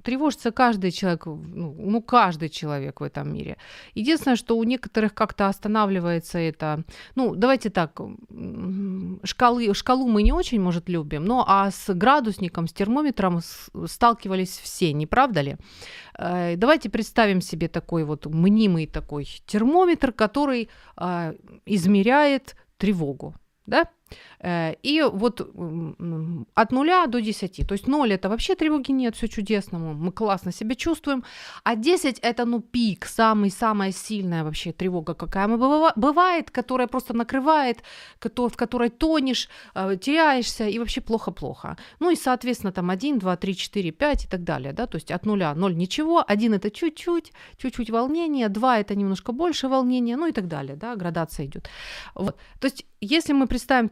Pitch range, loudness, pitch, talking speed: 180-255 Hz, -23 LUFS, 215 Hz, 145 wpm